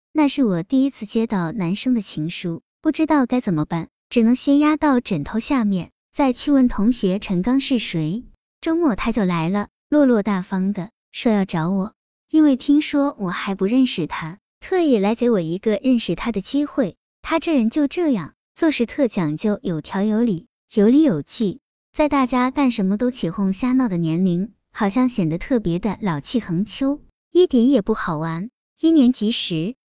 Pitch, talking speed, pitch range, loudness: 225 Hz, 260 characters per minute, 190-270 Hz, -20 LUFS